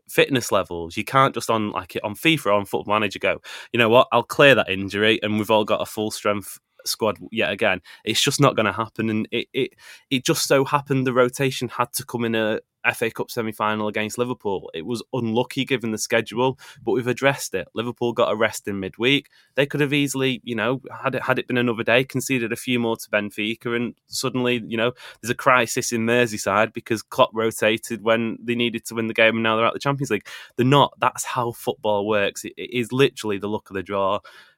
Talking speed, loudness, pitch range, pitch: 230 wpm, -22 LUFS, 110-130 Hz, 120 Hz